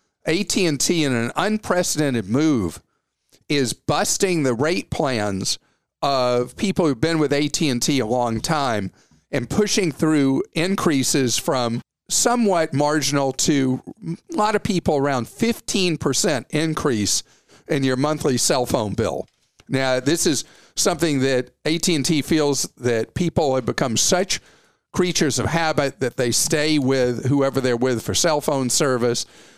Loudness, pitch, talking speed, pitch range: -20 LUFS, 145 Hz, 135 wpm, 130-165 Hz